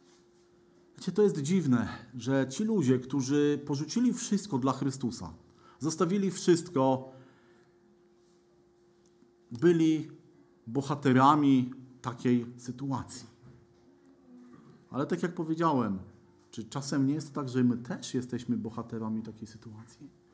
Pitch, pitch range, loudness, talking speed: 130 Hz, 120-165 Hz, -30 LUFS, 105 wpm